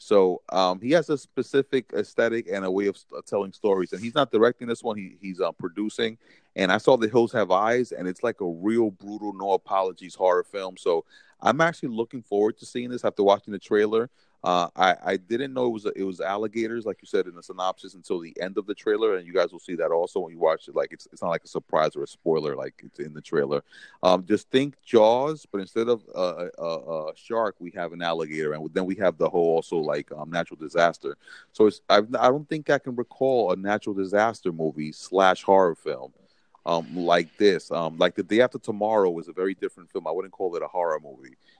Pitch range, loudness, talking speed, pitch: 90-125 Hz, -25 LUFS, 240 wpm, 105 Hz